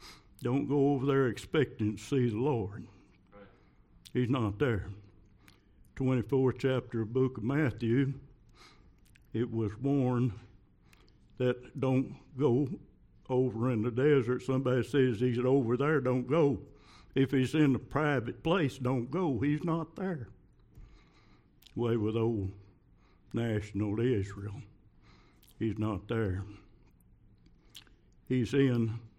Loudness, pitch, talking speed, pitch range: -31 LUFS, 125 Hz, 115 wpm, 105-135 Hz